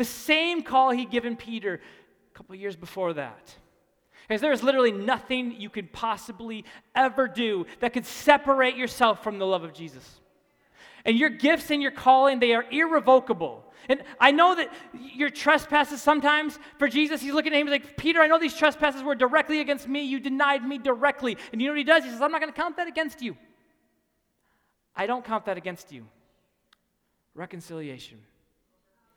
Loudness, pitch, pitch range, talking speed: -24 LUFS, 260 Hz, 220-290 Hz, 185 wpm